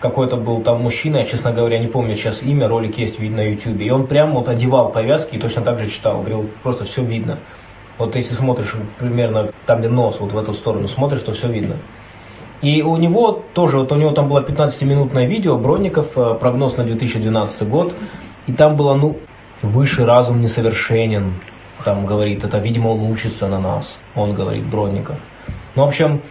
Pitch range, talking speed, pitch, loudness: 110-140 Hz, 190 wpm, 115 Hz, -17 LUFS